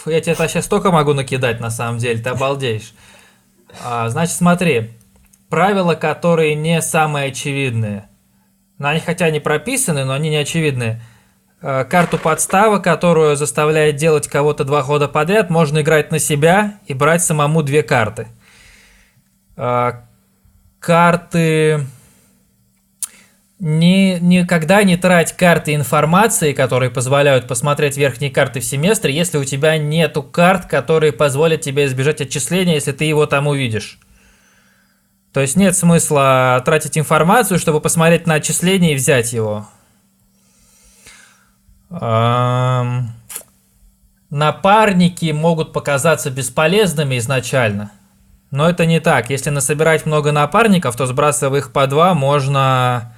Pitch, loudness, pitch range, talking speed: 150 Hz, -15 LUFS, 130-165 Hz, 120 wpm